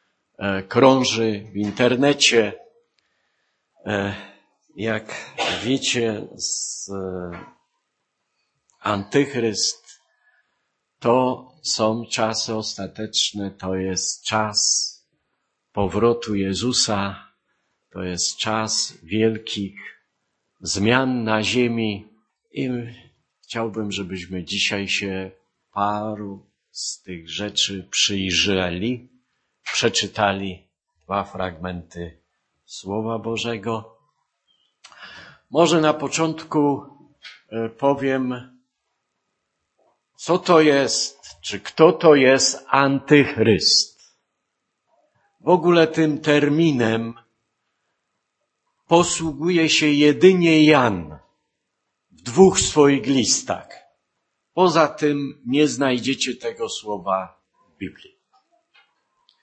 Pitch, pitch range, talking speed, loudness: 115 Hz, 100-145 Hz, 70 wpm, -20 LUFS